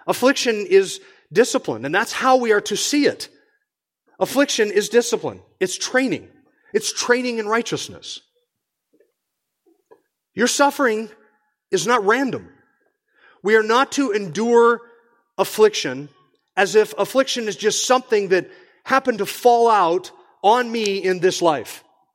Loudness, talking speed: -19 LUFS, 125 wpm